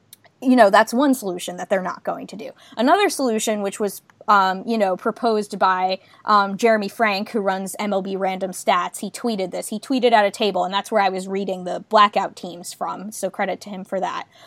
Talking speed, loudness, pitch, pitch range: 215 wpm, -20 LUFS, 200 Hz, 190-220 Hz